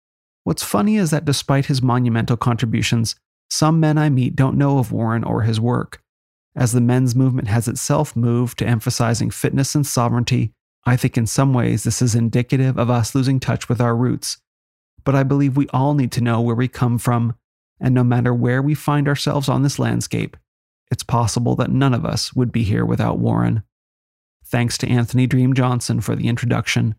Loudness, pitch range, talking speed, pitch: -18 LUFS, 115-135 Hz, 195 wpm, 125 Hz